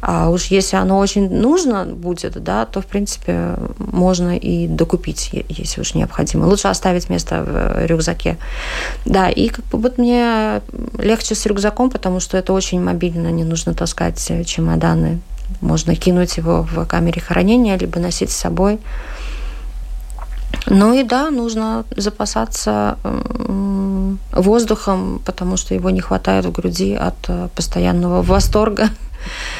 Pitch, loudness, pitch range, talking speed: 185 Hz, -17 LUFS, 165-215 Hz, 135 wpm